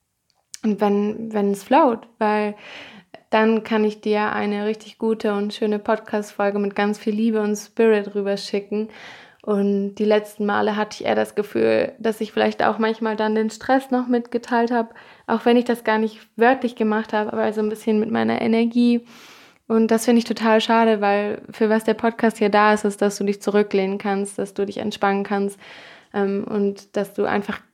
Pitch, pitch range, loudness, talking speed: 215 Hz, 205-225 Hz, -21 LUFS, 195 wpm